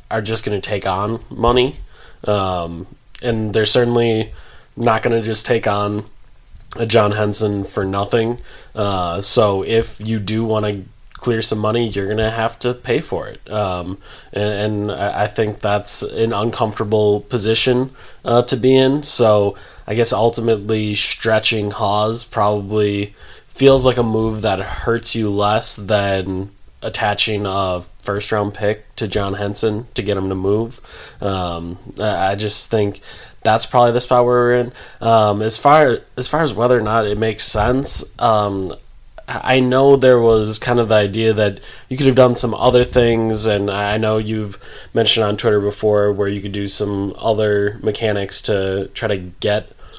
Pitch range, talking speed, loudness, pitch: 105-115 Hz, 165 wpm, -17 LUFS, 110 Hz